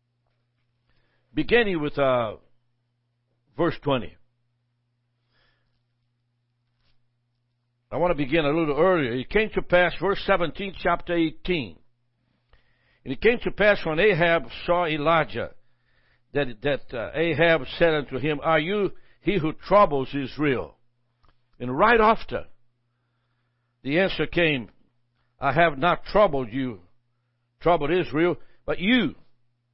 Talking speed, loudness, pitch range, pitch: 115 wpm, -23 LUFS, 120-170 Hz, 135 Hz